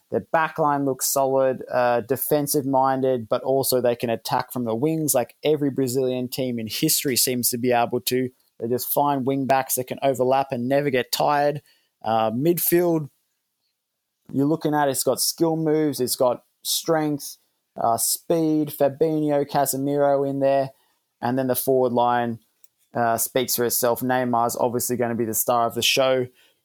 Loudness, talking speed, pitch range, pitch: -22 LUFS, 170 wpm, 125-145 Hz, 130 Hz